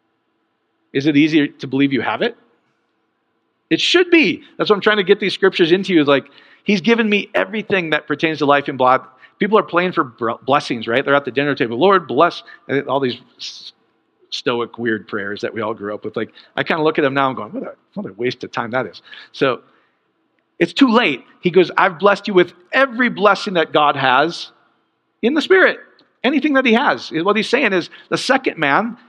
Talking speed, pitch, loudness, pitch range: 210 wpm, 180 Hz, -17 LUFS, 140-225 Hz